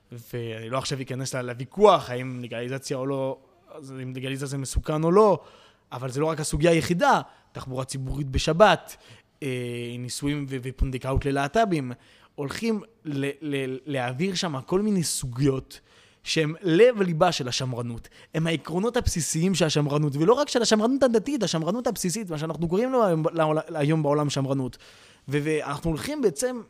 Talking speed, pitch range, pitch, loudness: 150 wpm, 130-170 Hz, 145 Hz, -25 LUFS